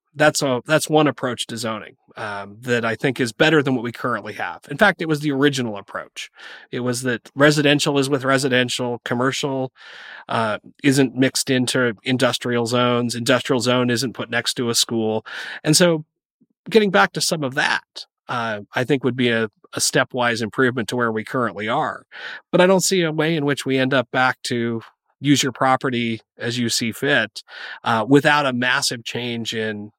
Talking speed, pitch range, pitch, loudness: 190 wpm, 120-145 Hz, 130 Hz, -20 LUFS